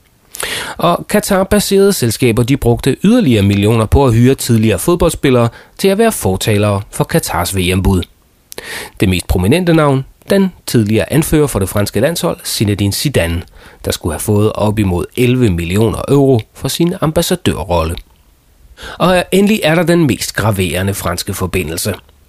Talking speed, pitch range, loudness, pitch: 145 wpm, 95-165 Hz, -13 LUFS, 115 Hz